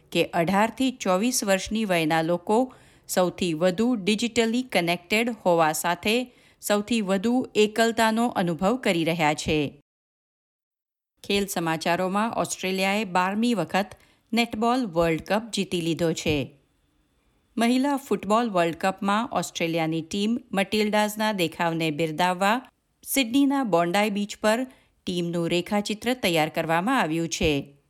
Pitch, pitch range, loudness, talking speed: 200 Hz, 170-230 Hz, -24 LUFS, 105 wpm